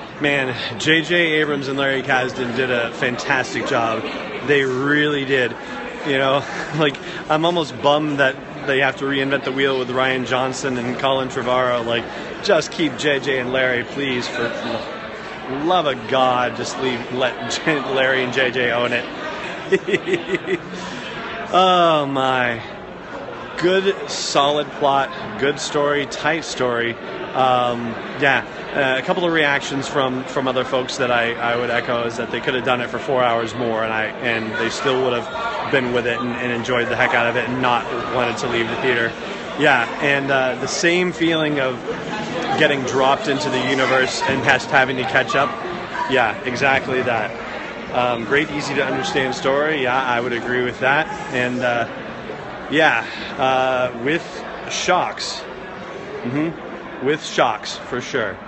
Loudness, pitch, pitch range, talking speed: -19 LUFS, 130 Hz, 125-145 Hz, 160 wpm